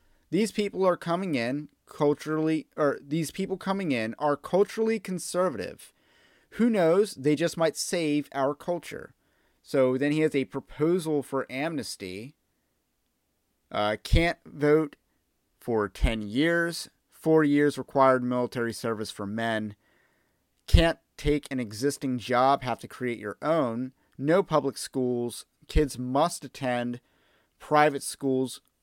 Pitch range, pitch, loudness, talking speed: 125-160 Hz, 140 Hz, -27 LUFS, 125 wpm